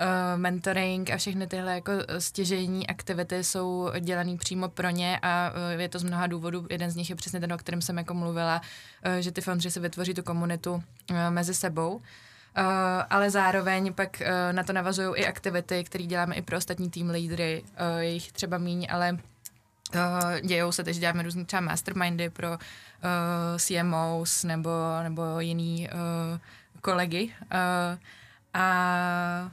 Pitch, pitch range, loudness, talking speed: 175 Hz, 170-185 Hz, -29 LUFS, 145 wpm